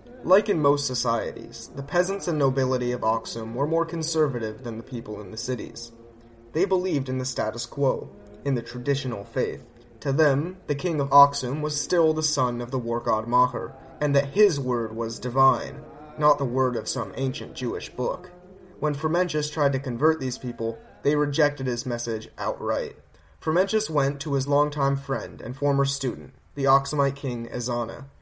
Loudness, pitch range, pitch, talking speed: -25 LUFS, 120-150 Hz, 135 Hz, 175 wpm